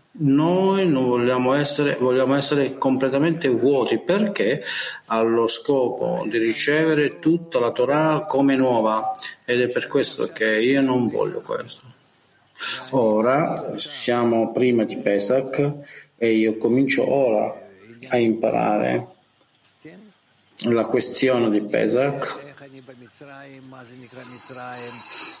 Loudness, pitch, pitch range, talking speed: -20 LUFS, 130 Hz, 120-145 Hz, 100 wpm